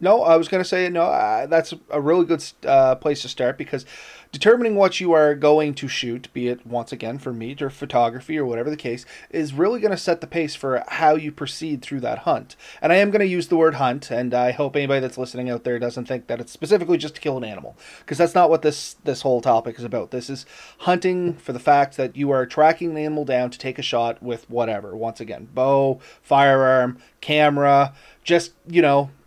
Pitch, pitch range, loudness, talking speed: 145 Hz, 125-165 Hz, -21 LUFS, 230 wpm